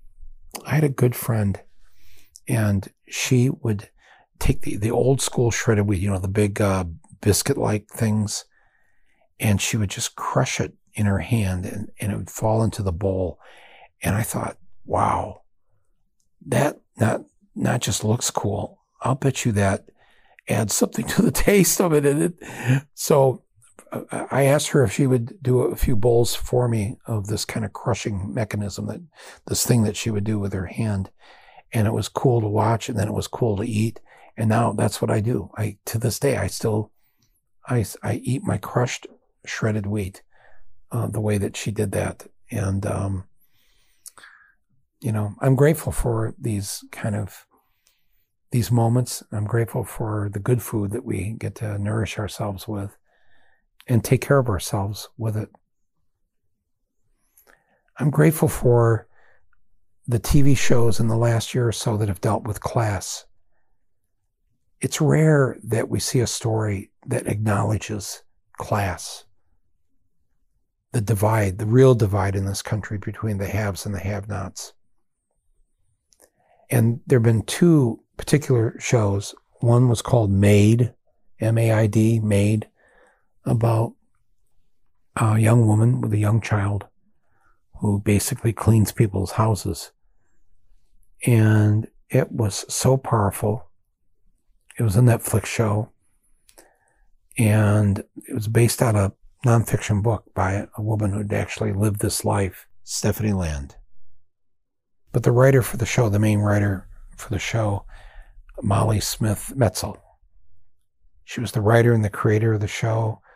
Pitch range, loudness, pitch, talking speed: 100-120 Hz, -22 LUFS, 110 Hz, 150 wpm